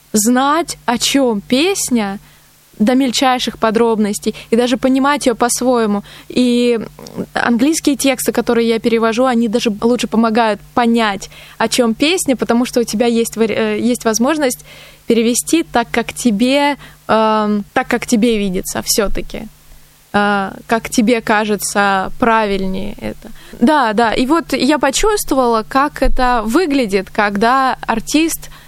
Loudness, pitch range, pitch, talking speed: -14 LUFS, 220-260 Hz, 235 Hz, 120 wpm